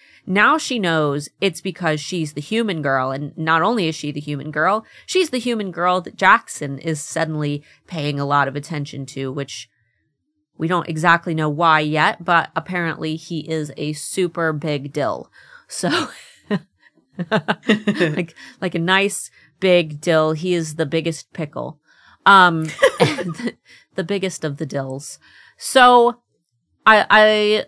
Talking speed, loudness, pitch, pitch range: 145 wpm, -19 LUFS, 165 Hz, 150-190 Hz